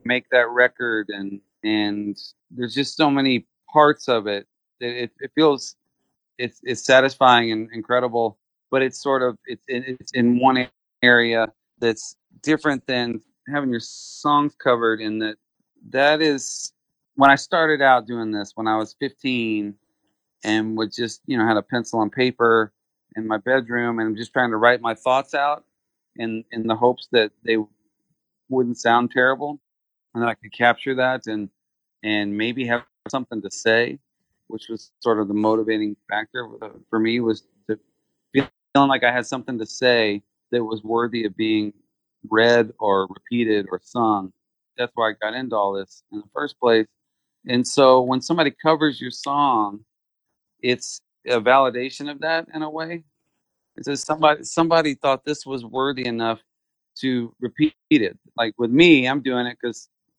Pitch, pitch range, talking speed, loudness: 120 Hz, 110-135 Hz, 170 wpm, -21 LUFS